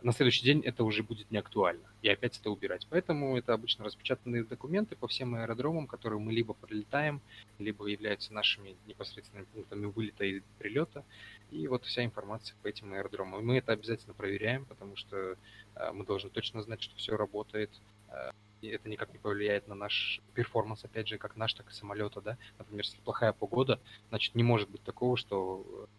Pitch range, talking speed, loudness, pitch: 105-120 Hz, 180 wpm, -34 LUFS, 110 Hz